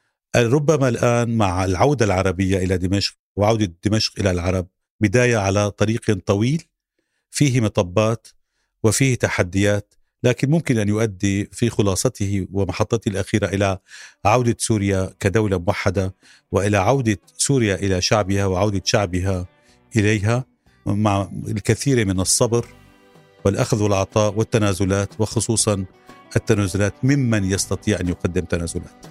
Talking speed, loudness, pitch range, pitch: 110 wpm, -20 LUFS, 95-115 Hz, 105 Hz